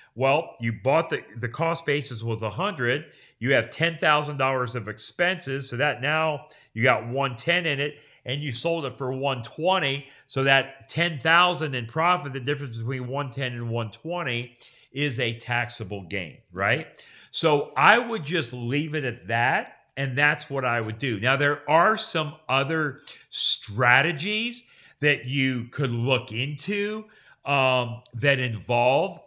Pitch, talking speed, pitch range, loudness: 135 Hz, 150 wpm, 125-155 Hz, -24 LUFS